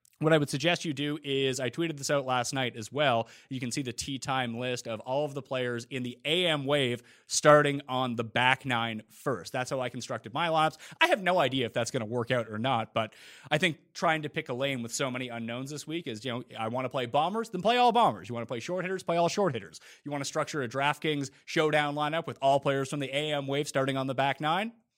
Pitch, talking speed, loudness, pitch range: 135 Hz, 265 wpm, -29 LUFS, 125-155 Hz